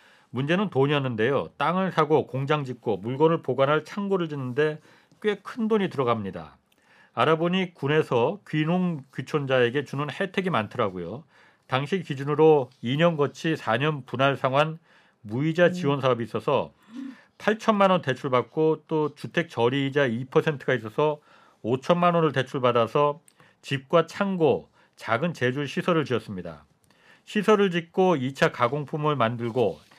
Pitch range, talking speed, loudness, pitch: 130-175 Hz, 285 characters per minute, -25 LUFS, 150 Hz